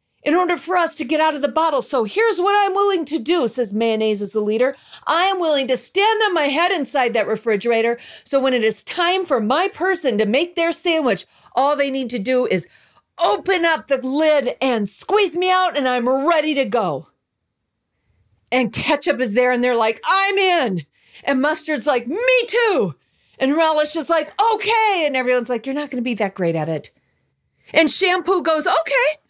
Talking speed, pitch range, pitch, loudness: 205 wpm, 245-350 Hz, 290 Hz, -18 LUFS